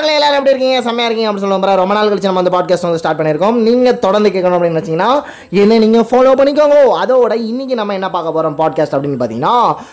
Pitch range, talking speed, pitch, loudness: 180-250 Hz, 220 wpm, 210 Hz, -12 LUFS